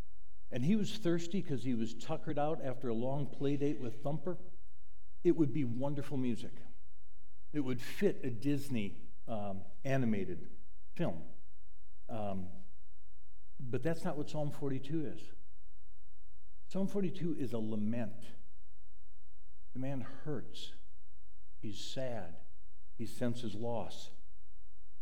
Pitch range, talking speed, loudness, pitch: 95-140 Hz, 120 wpm, -39 LUFS, 115 Hz